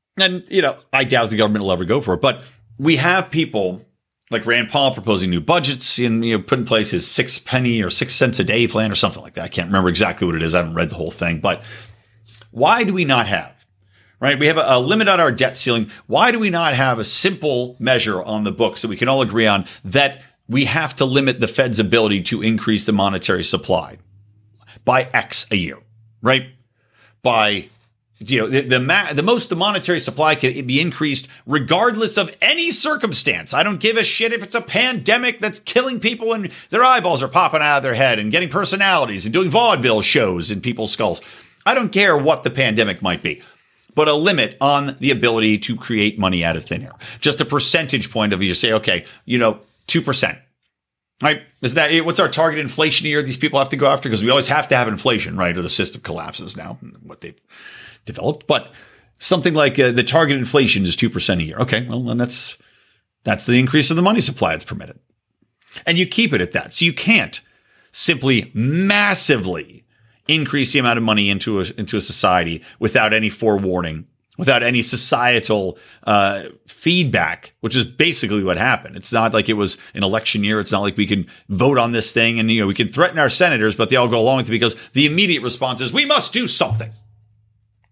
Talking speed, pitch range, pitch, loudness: 215 wpm, 110-155 Hz, 125 Hz, -17 LUFS